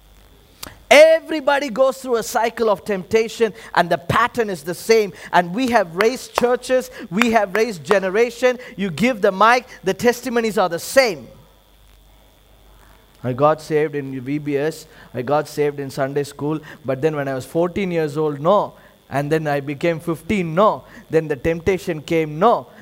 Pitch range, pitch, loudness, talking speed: 155-230 Hz, 190 Hz, -19 LUFS, 165 wpm